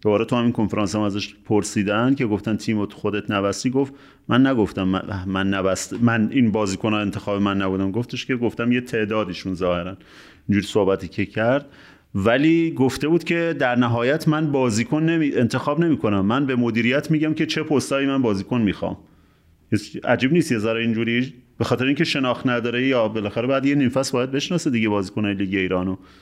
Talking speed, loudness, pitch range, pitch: 170 wpm, -21 LUFS, 100-130 Hz, 115 Hz